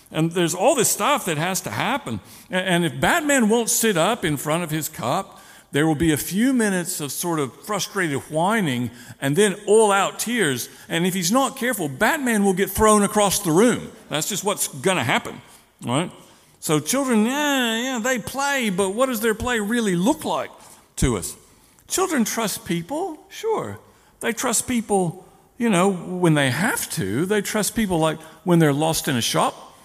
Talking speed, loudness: 190 wpm, -21 LUFS